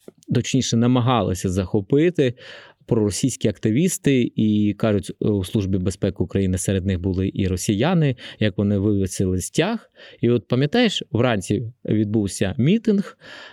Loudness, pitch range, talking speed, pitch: -21 LUFS, 100-130 Hz, 115 wpm, 110 Hz